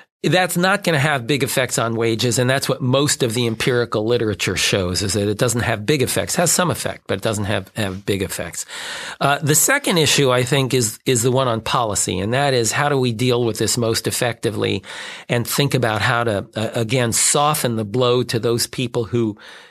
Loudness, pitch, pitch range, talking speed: -18 LUFS, 120 Hz, 110-135 Hz, 220 wpm